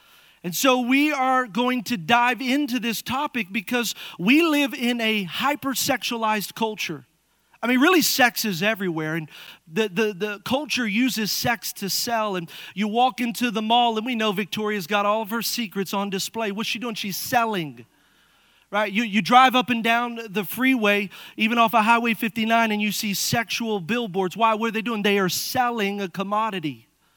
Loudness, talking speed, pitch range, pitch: -22 LUFS, 185 wpm, 205-245 Hz, 225 Hz